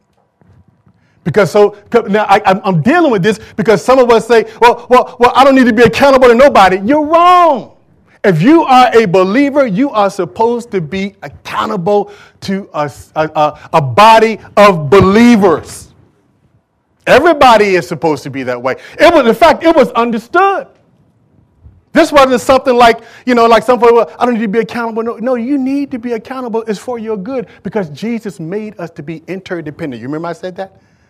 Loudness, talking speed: -10 LUFS, 190 wpm